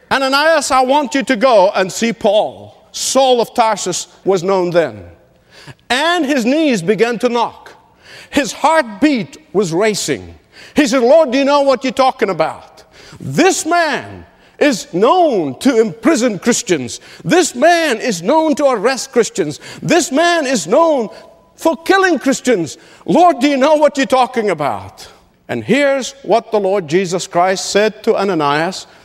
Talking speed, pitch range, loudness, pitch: 155 wpm, 195-295 Hz, -14 LUFS, 255 Hz